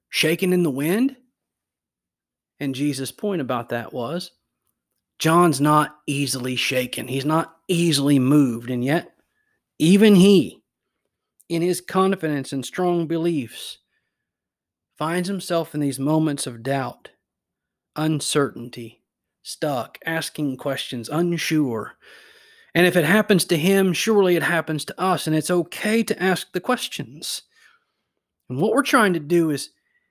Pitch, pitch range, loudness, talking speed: 165 Hz, 145-185 Hz, -21 LUFS, 130 wpm